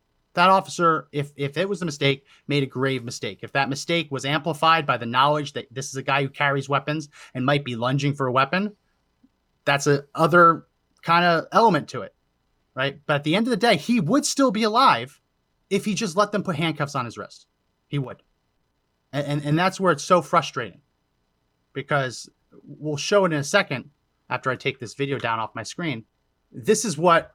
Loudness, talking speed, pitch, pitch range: -22 LUFS, 210 wpm, 145 Hz, 130-170 Hz